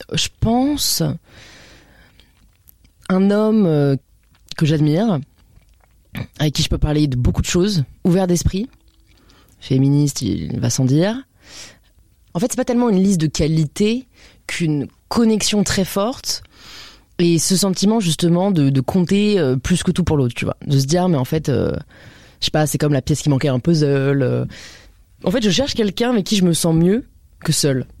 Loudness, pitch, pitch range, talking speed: -18 LUFS, 155 Hz, 120-190 Hz, 170 wpm